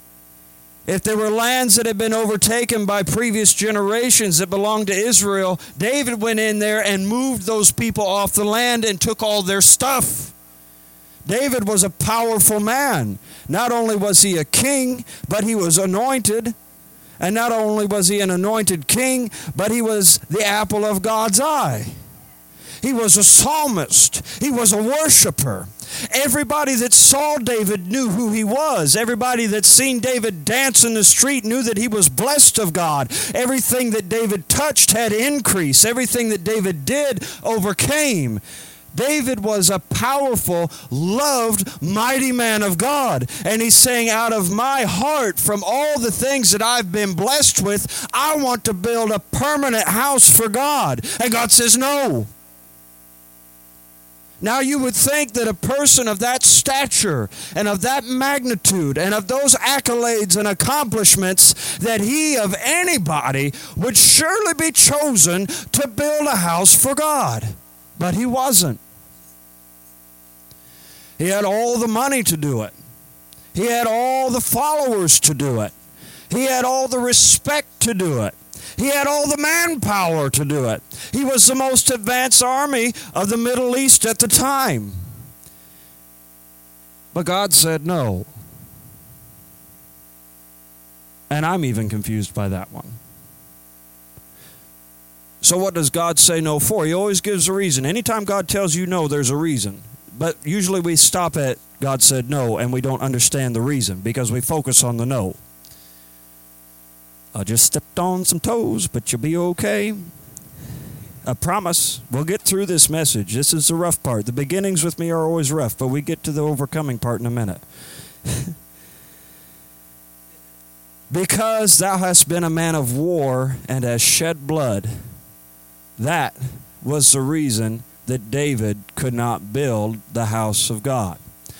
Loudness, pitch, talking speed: -16 LUFS, 185 Hz, 155 wpm